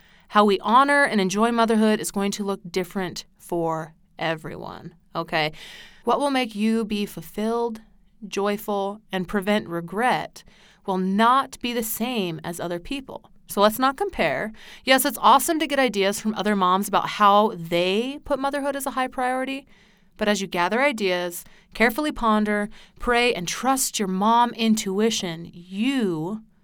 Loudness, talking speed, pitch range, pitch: -23 LUFS, 155 wpm, 185-240 Hz, 210 Hz